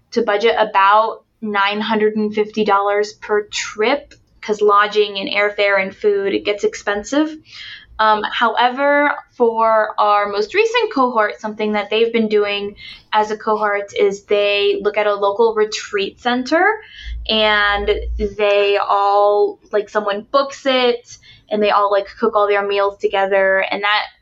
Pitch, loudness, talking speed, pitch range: 210 Hz, -16 LUFS, 140 wpm, 205-230 Hz